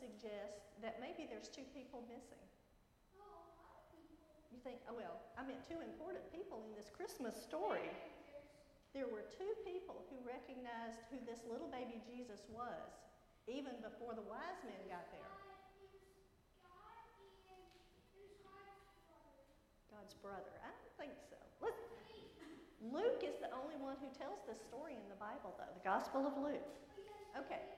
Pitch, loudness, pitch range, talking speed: 275 Hz, -50 LUFS, 235-385 Hz, 140 wpm